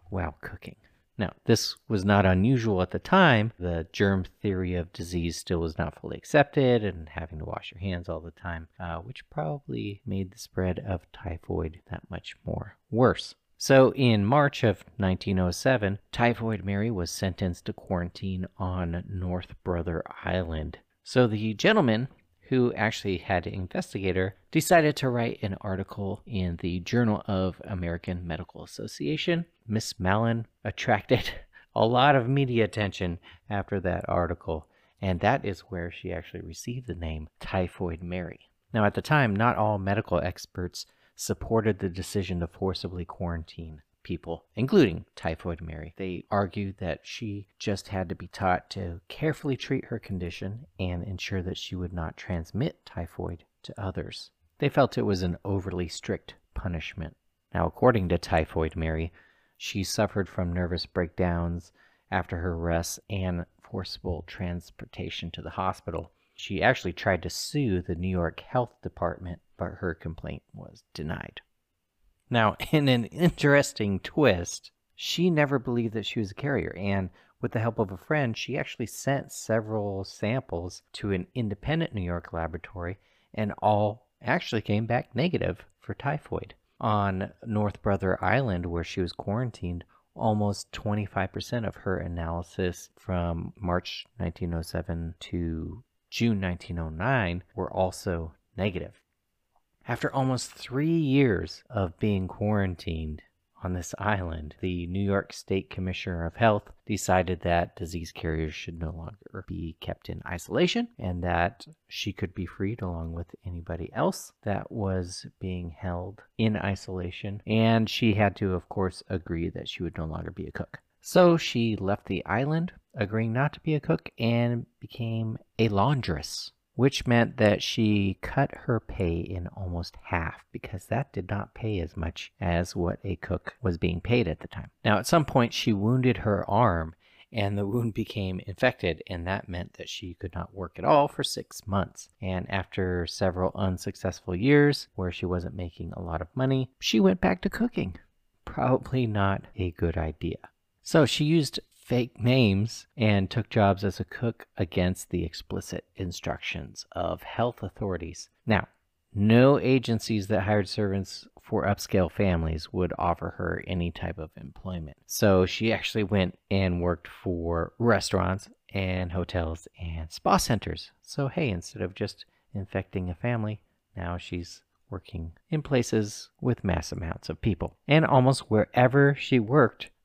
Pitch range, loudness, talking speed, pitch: 90-110 Hz, -28 LUFS, 155 wpm, 95 Hz